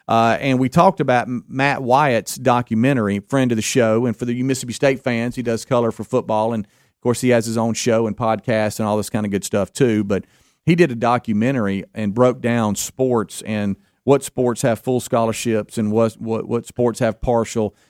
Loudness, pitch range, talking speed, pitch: -19 LUFS, 110-125 Hz, 210 wpm, 115 Hz